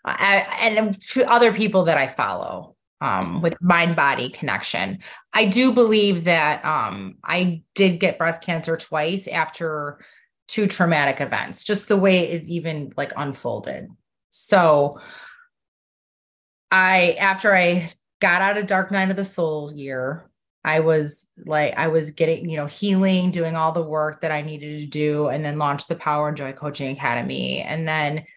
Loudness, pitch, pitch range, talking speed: -20 LUFS, 165 Hz, 150-190 Hz, 160 wpm